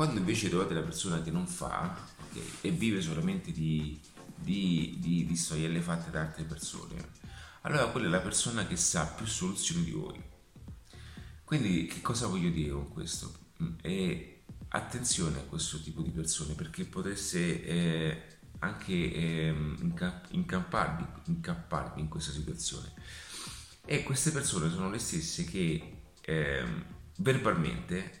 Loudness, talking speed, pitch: -33 LUFS, 135 wpm, 85 Hz